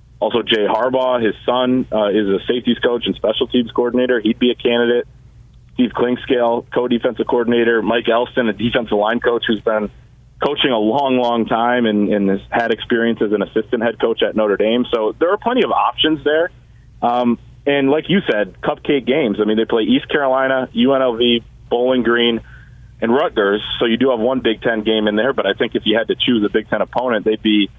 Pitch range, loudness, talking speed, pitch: 110-125 Hz, -17 LUFS, 210 wpm, 120 Hz